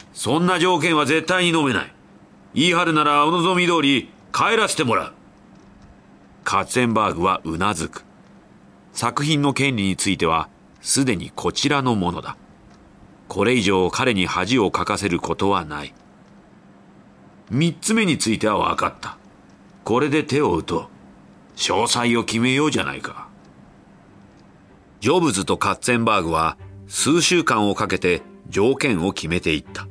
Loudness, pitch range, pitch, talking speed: -20 LUFS, 100-155 Hz, 125 Hz, 285 characters per minute